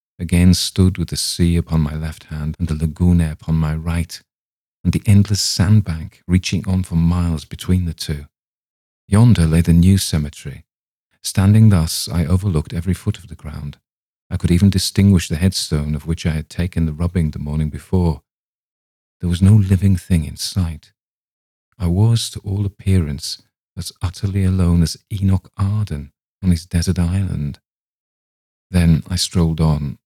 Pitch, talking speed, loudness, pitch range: 85 Hz, 165 wpm, -18 LUFS, 80-95 Hz